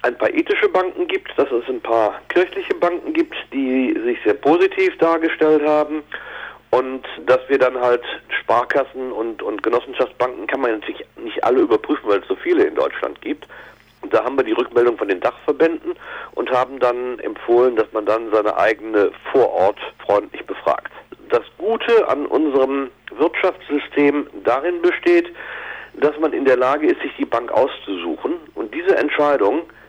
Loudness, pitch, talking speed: -19 LUFS, 300 Hz, 165 wpm